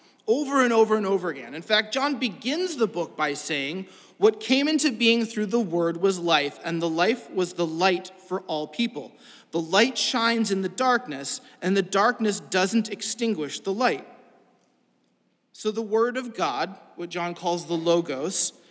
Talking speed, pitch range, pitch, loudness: 175 wpm, 175-235 Hz, 205 Hz, -24 LUFS